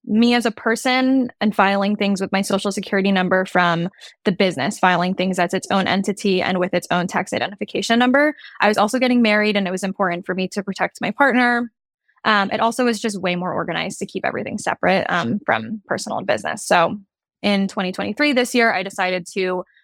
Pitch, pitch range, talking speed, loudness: 200 Hz, 185-230 Hz, 205 wpm, -19 LUFS